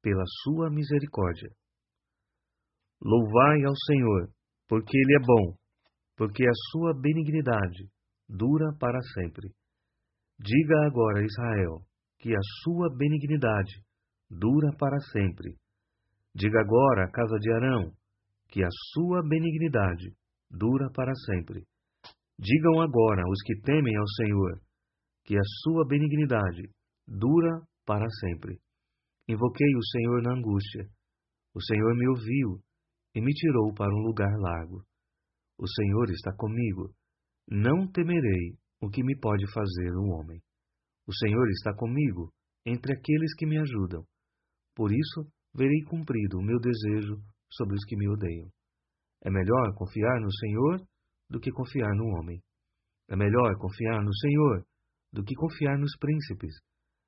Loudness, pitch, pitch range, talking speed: -28 LUFS, 110 Hz, 100-135 Hz, 130 wpm